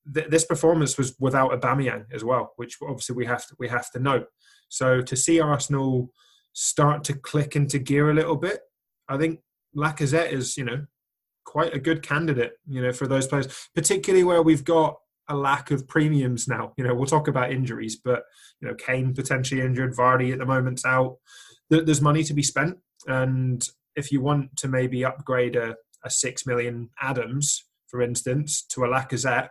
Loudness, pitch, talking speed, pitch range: -24 LUFS, 135 Hz, 185 wpm, 125-150 Hz